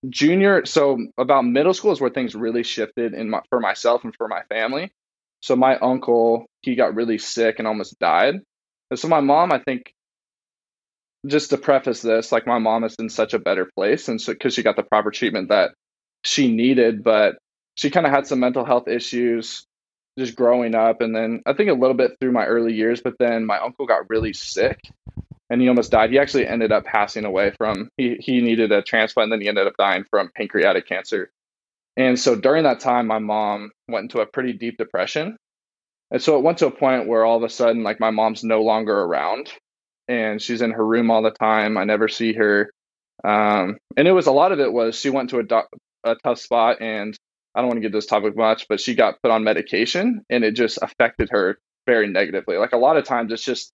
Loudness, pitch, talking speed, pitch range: -20 LUFS, 115 Hz, 225 wpm, 110-125 Hz